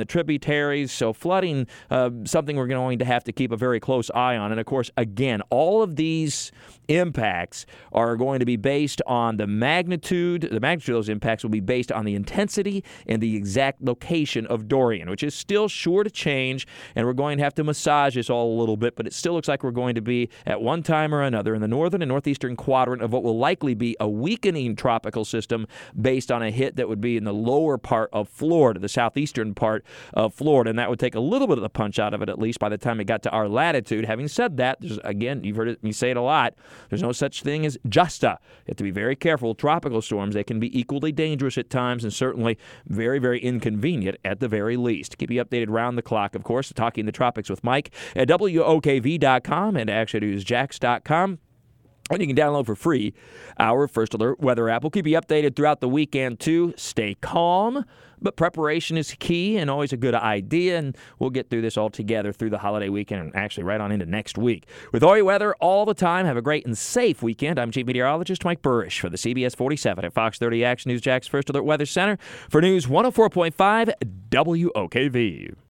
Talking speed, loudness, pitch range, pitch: 225 wpm, -23 LUFS, 115-150 Hz, 125 Hz